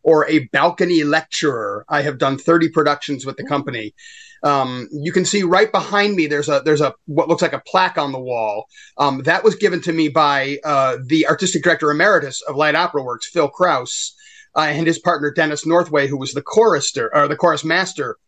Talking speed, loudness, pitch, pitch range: 205 wpm, -17 LUFS, 160 Hz, 145-185 Hz